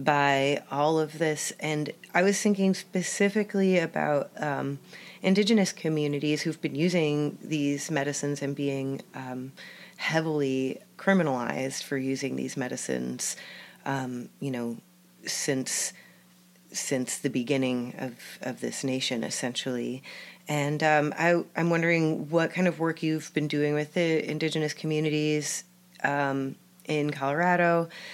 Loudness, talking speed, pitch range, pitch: -28 LUFS, 125 wpm, 135-170 Hz, 150 Hz